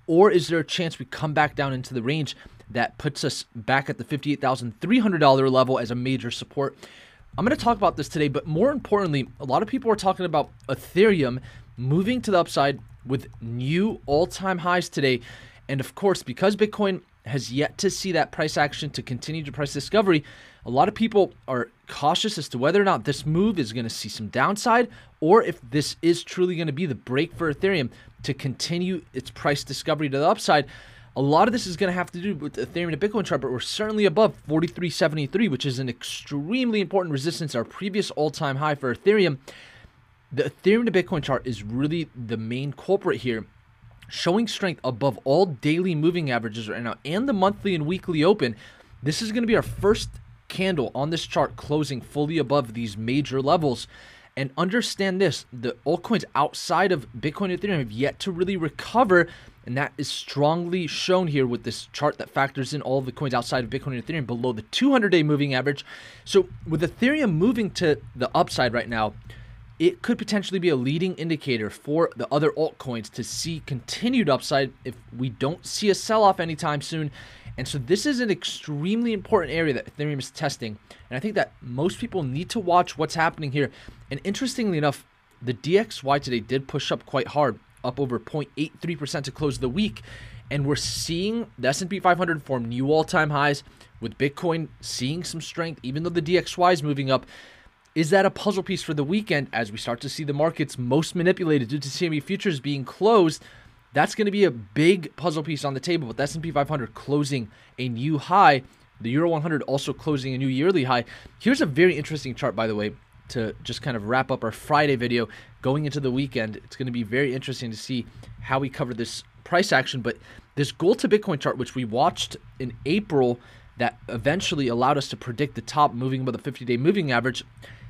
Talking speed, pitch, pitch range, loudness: 200 wpm, 145 Hz, 125-175 Hz, -24 LUFS